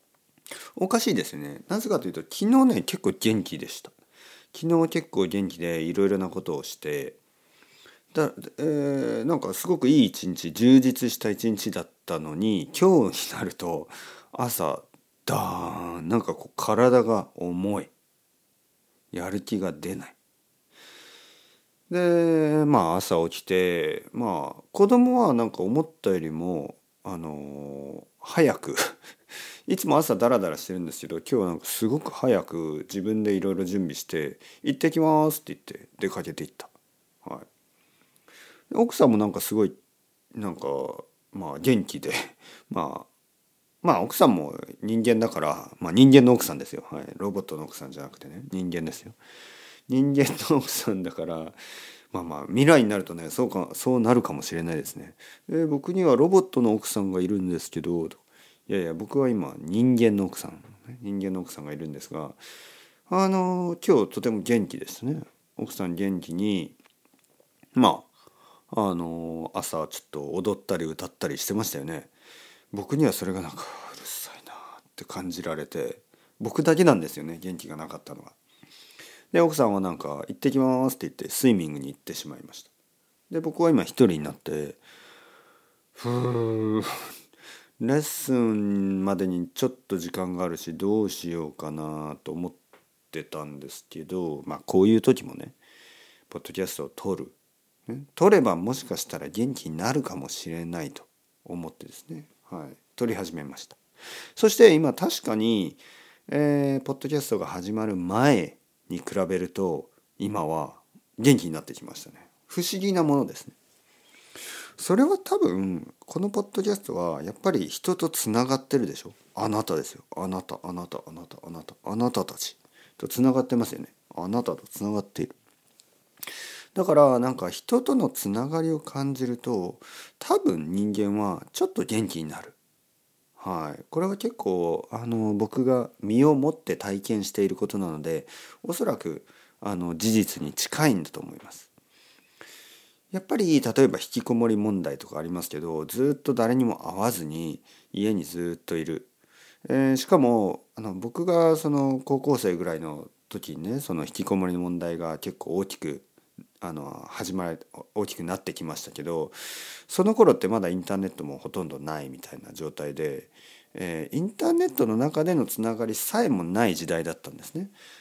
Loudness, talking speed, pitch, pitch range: -26 LUFS, 320 characters per minute, 110 Hz, 90-145 Hz